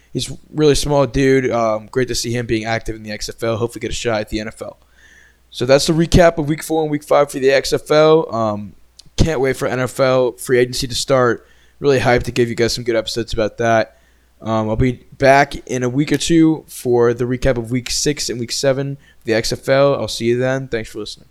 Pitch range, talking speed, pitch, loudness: 115-140 Hz, 230 wpm, 125 Hz, -17 LUFS